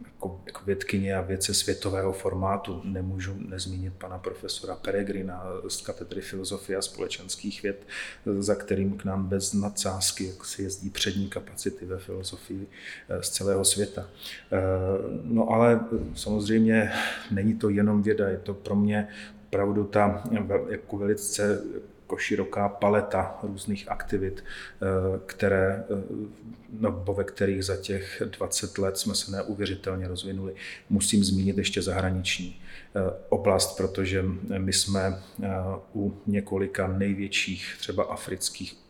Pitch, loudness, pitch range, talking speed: 100 Hz, -28 LUFS, 95-100 Hz, 120 wpm